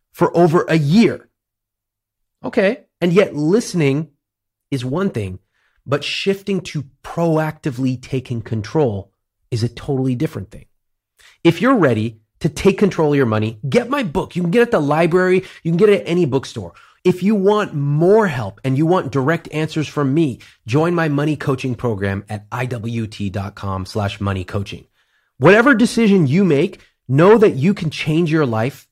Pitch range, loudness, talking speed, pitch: 115-175 Hz, -17 LUFS, 165 wpm, 145 Hz